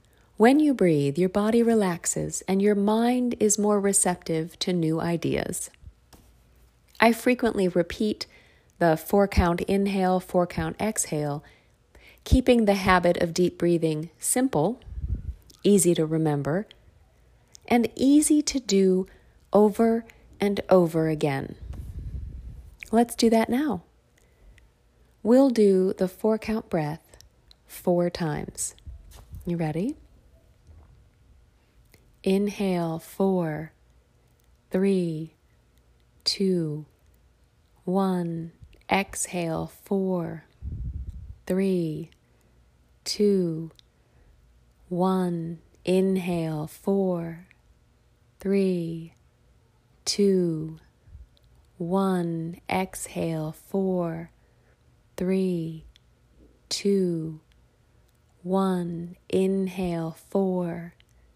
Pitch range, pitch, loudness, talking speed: 155-195 Hz, 175 Hz, -25 LUFS, 75 wpm